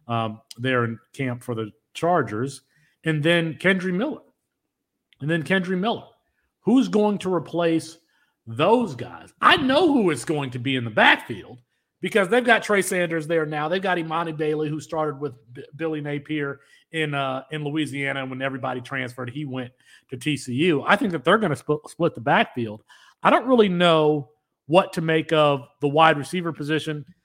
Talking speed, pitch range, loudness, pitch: 180 wpm, 135-175 Hz, -22 LUFS, 155 Hz